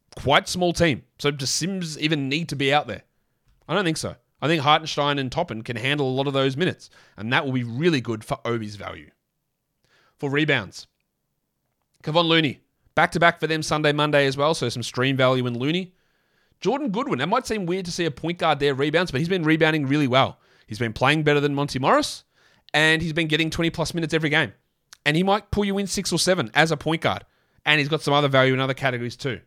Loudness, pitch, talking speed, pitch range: -22 LUFS, 150 Hz, 230 wpm, 130-165 Hz